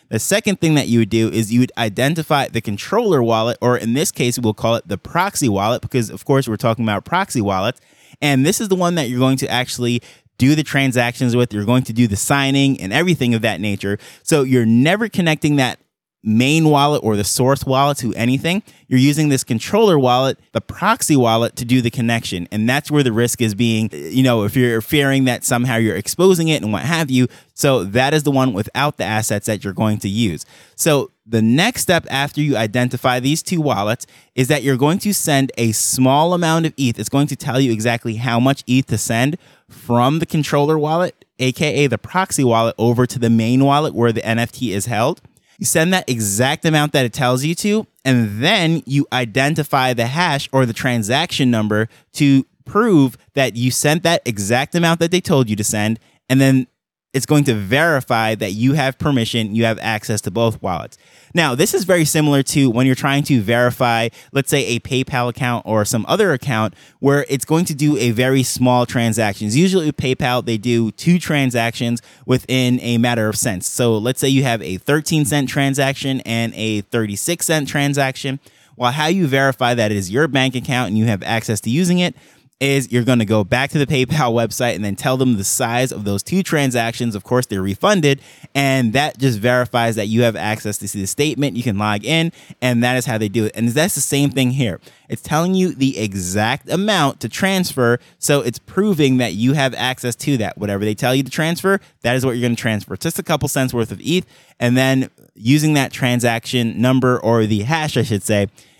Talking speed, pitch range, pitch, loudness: 215 wpm, 115-145 Hz, 130 Hz, -17 LUFS